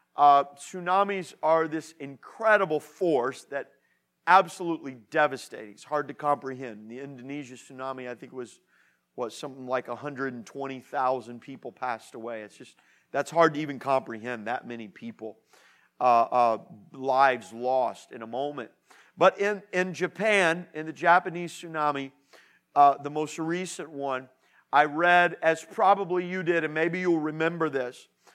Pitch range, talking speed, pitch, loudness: 130-170 Hz, 150 wpm, 145 Hz, -26 LUFS